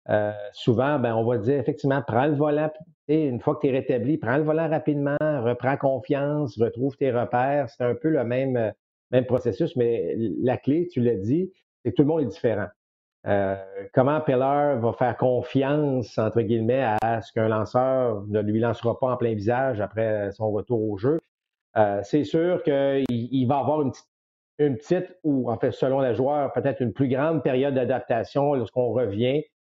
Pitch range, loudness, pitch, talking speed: 115-145 Hz, -24 LUFS, 130 Hz, 190 wpm